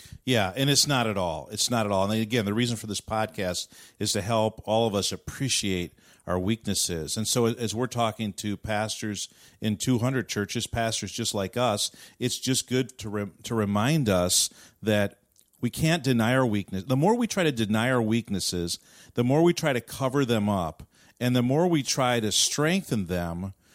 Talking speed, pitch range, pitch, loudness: 195 wpm, 100-125 Hz, 110 Hz, -26 LUFS